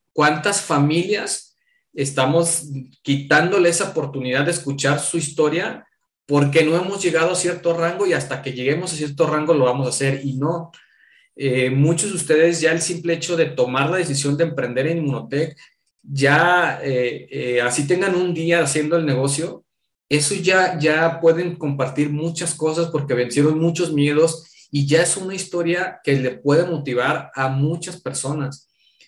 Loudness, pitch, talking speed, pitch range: -19 LUFS, 155 Hz, 165 wpm, 140-170 Hz